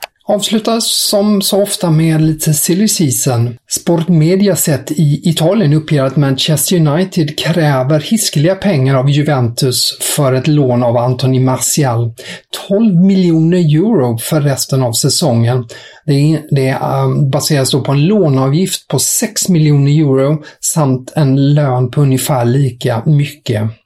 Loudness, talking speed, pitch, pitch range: -12 LUFS, 135 wpm, 150 Hz, 130-170 Hz